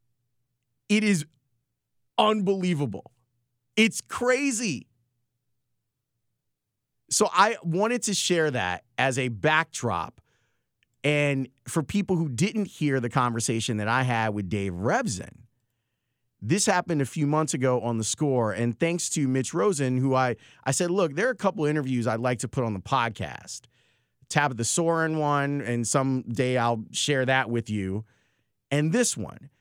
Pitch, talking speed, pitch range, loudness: 130 Hz, 150 wpm, 120-160 Hz, -26 LUFS